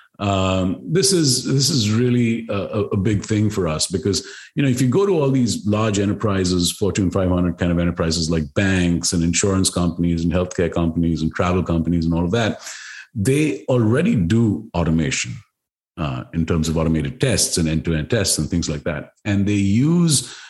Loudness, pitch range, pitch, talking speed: -19 LUFS, 85-110 Hz, 95 Hz, 185 wpm